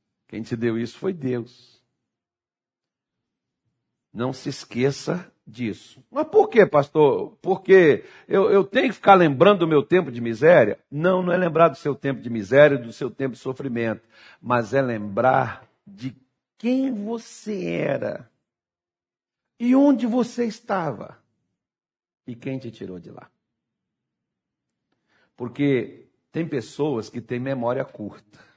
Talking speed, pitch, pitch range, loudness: 135 wpm, 135 Hz, 120-195 Hz, -21 LUFS